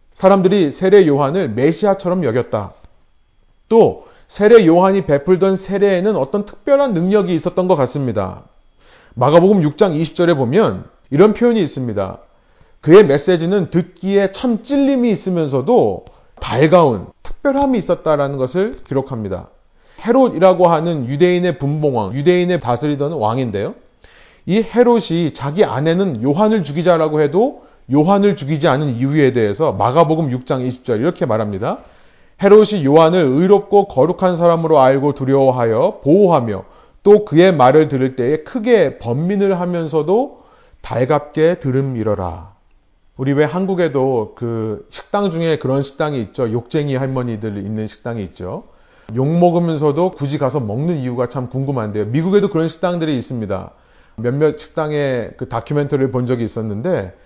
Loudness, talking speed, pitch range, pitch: -15 LUFS, 330 characters per minute, 130-185 Hz, 155 Hz